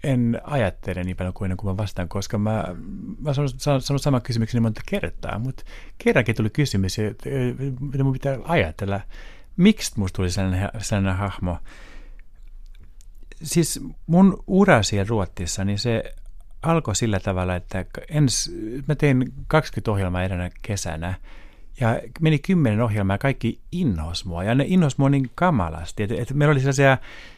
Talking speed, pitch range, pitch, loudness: 150 wpm, 95-140 Hz, 110 Hz, -23 LUFS